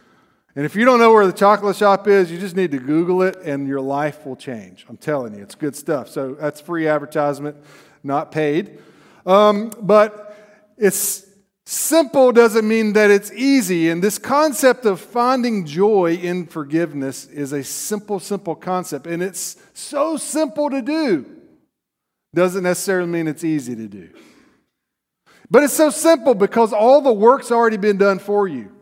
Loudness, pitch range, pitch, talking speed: -17 LUFS, 160-225 Hz, 200 Hz, 170 wpm